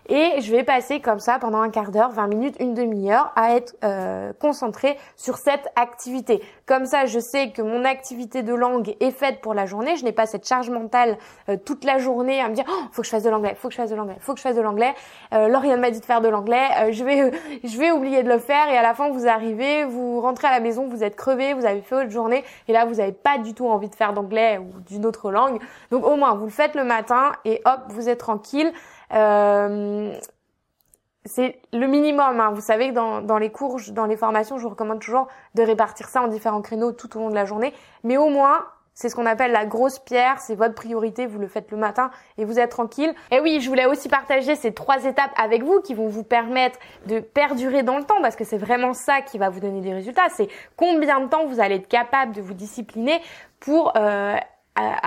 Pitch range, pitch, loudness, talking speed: 220-270 Hz, 240 Hz, -21 LUFS, 250 wpm